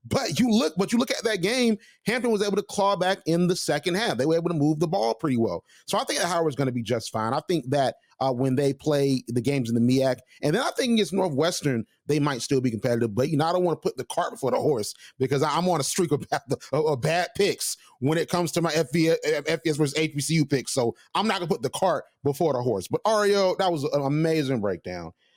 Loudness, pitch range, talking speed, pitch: -25 LUFS, 135-180 Hz, 265 wpm, 155 Hz